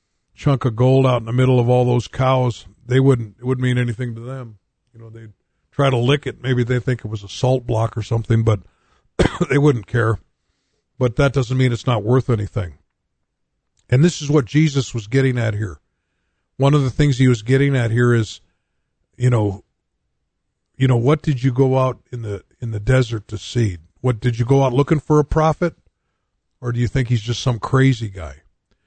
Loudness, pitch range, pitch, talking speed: -18 LUFS, 110-130 Hz, 125 Hz, 210 wpm